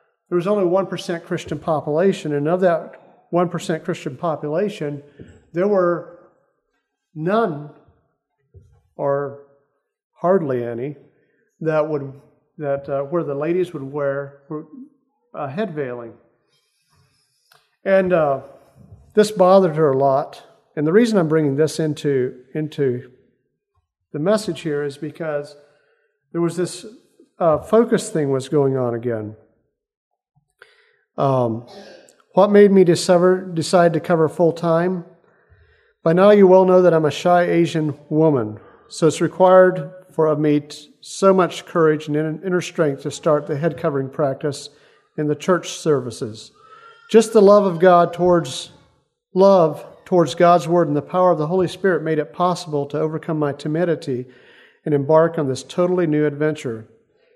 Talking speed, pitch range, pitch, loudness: 140 wpm, 145-185 Hz, 160 Hz, -18 LUFS